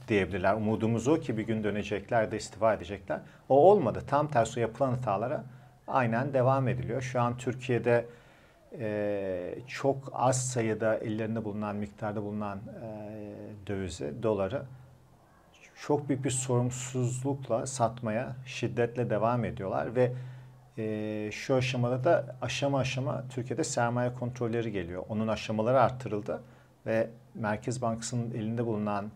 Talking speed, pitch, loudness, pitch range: 125 wpm, 115 Hz, -30 LUFS, 110-125 Hz